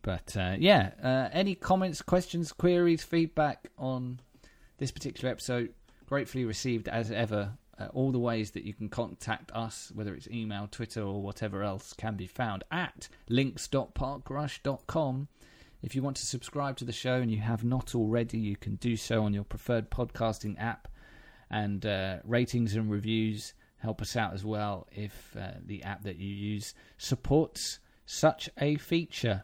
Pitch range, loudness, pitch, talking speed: 105-135 Hz, -32 LUFS, 115 Hz, 165 wpm